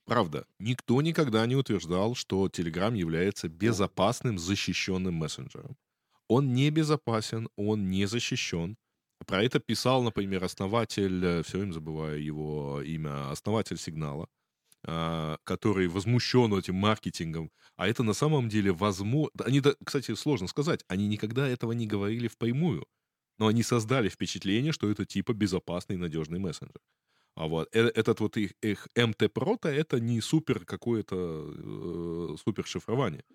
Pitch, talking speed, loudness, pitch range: 105 Hz, 130 wpm, -30 LUFS, 90-120 Hz